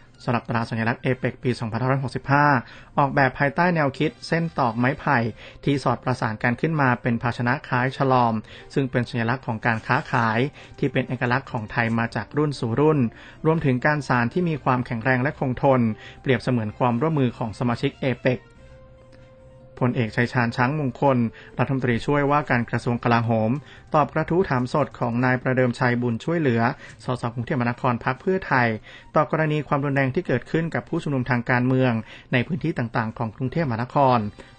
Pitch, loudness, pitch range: 130 Hz, -23 LUFS, 120-140 Hz